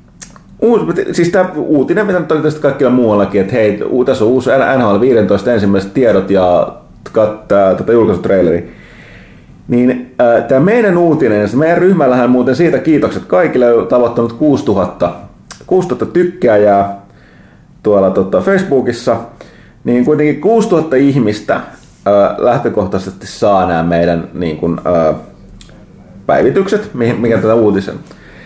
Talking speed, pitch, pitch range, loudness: 120 wpm, 125 Hz, 105-170 Hz, -11 LUFS